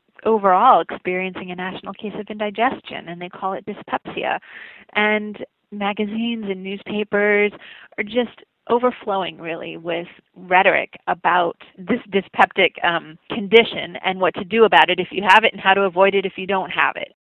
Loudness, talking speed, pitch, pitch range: -19 LUFS, 165 wpm, 195 Hz, 185-215 Hz